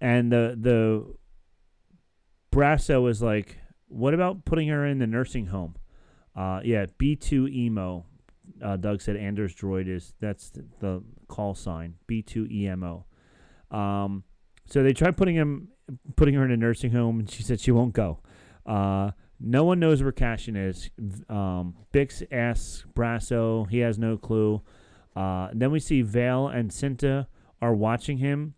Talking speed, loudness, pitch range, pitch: 150 wpm, -26 LUFS, 95-130 Hz, 115 Hz